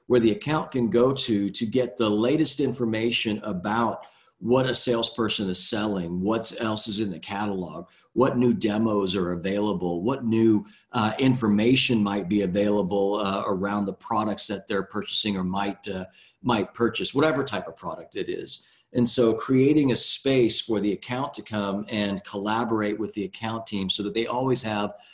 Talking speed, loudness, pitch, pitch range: 180 wpm, -24 LUFS, 110 Hz, 100-120 Hz